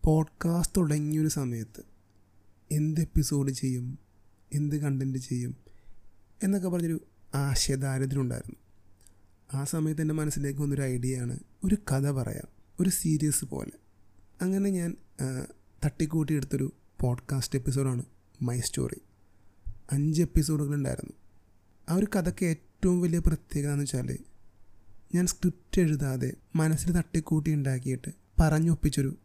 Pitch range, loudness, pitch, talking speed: 110-160 Hz, -30 LUFS, 140 Hz, 105 wpm